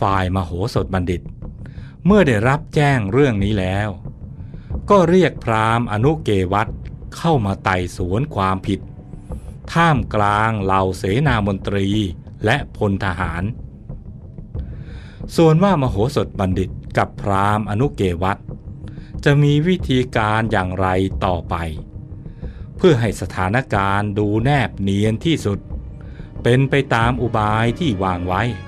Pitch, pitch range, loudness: 105 Hz, 95-130 Hz, -18 LUFS